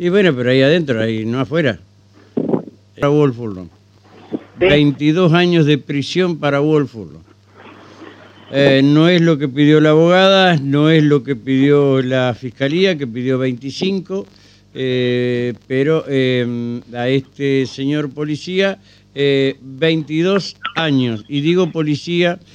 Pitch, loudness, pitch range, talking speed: 140 Hz, -15 LUFS, 125-160 Hz, 120 wpm